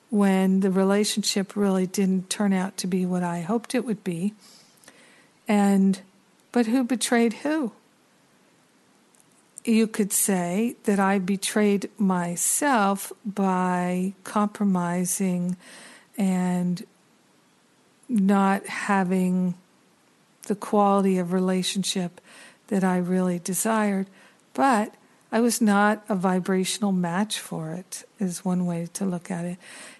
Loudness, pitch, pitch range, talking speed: -24 LUFS, 195 Hz, 185-215 Hz, 110 wpm